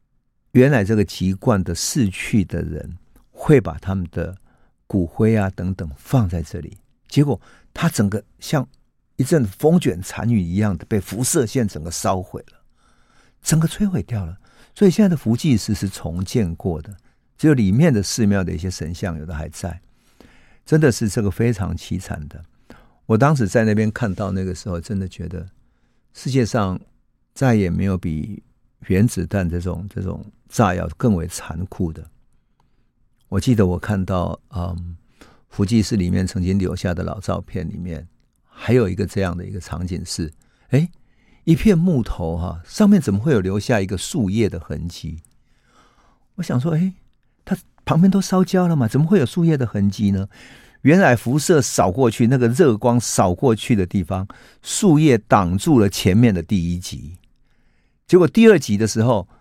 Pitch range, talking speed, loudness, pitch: 90-125 Hz, 250 characters per minute, -19 LUFS, 105 Hz